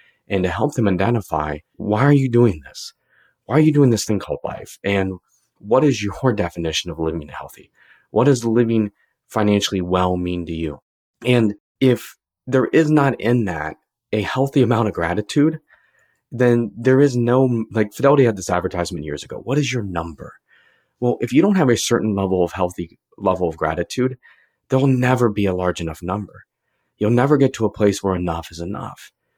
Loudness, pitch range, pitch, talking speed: -19 LUFS, 90-125 Hz, 110 Hz, 185 wpm